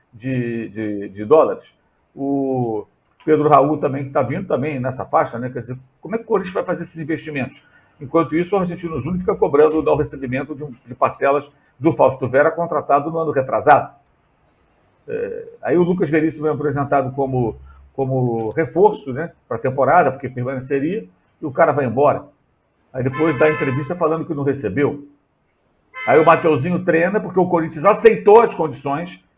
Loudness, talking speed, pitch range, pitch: -18 LUFS, 170 wpm, 130-165 Hz, 145 Hz